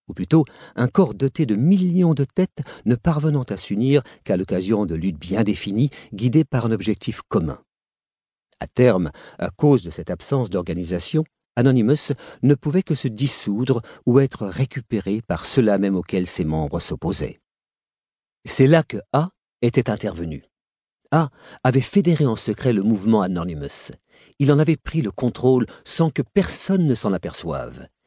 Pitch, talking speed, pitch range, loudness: 125 Hz, 160 wpm, 100-145 Hz, -21 LUFS